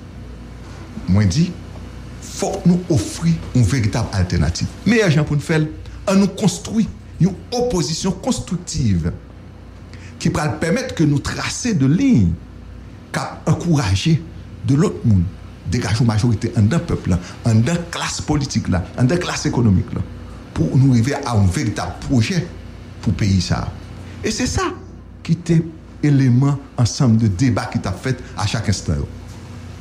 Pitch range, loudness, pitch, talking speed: 100-150 Hz, -19 LUFS, 115 Hz, 145 wpm